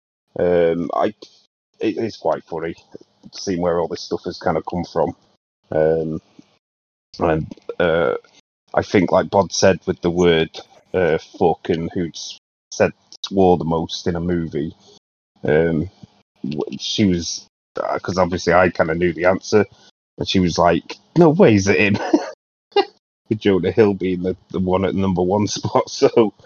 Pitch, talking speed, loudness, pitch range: 90 Hz, 165 wpm, -19 LUFS, 85-95 Hz